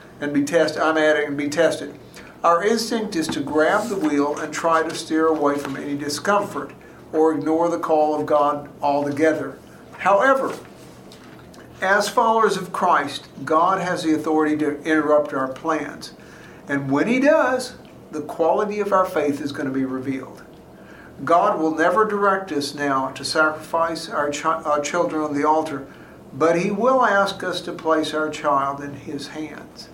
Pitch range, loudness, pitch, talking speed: 145-170 Hz, -21 LUFS, 155 Hz, 170 wpm